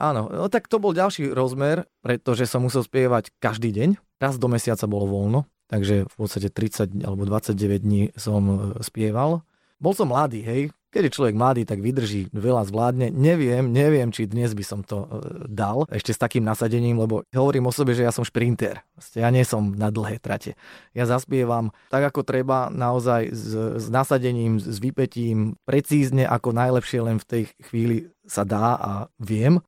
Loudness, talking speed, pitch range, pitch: -23 LUFS, 175 wpm, 110-135 Hz, 120 Hz